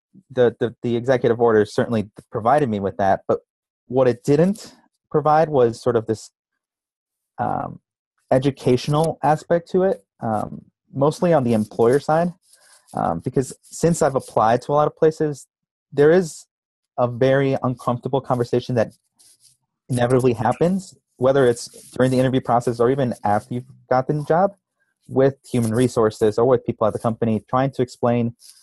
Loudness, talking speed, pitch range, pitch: -20 LUFS, 155 wpm, 120-150 Hz, 130 Hz